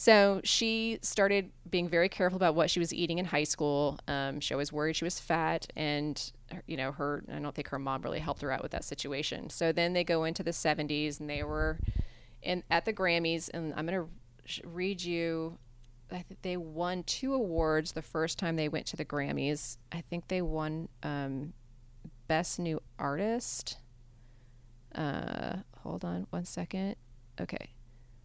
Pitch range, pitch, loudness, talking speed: 140-175 Hz, 160 Hz, -33 LUFS, 180 wpm